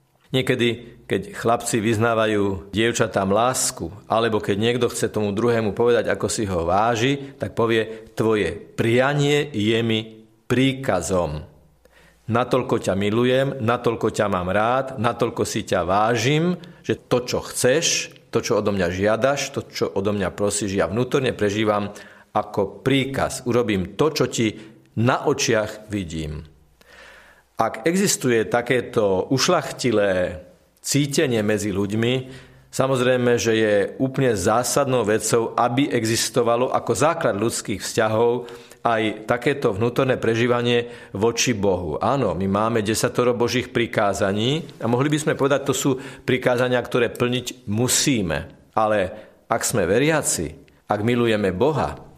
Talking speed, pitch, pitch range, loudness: 125 wpm, 120 Hz, 105-130 Hz, -21 LUFS